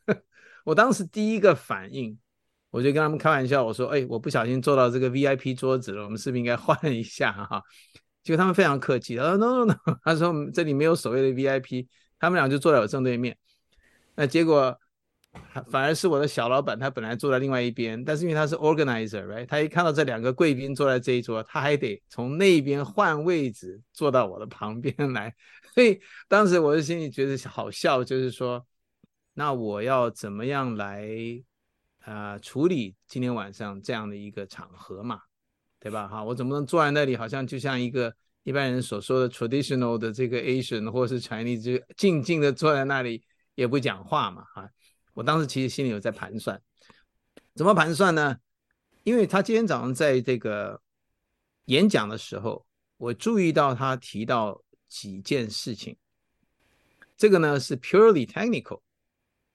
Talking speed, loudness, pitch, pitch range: 320 characters per minute, -25 LUFS, 130 Hz, 120-155 Hz